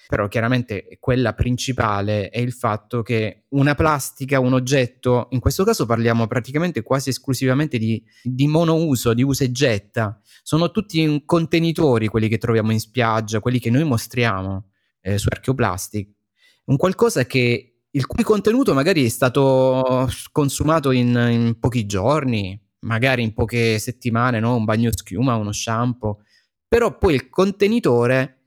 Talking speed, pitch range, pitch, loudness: 145 wpm, 115-135 Hz, 125 Hz, -20 LUFS